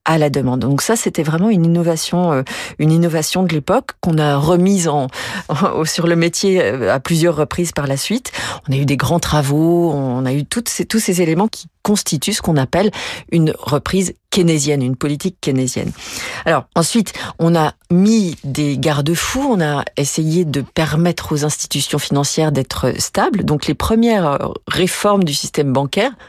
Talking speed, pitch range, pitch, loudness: 175 wpm, 145-180 Hz, 165 Hz, -16 LUFS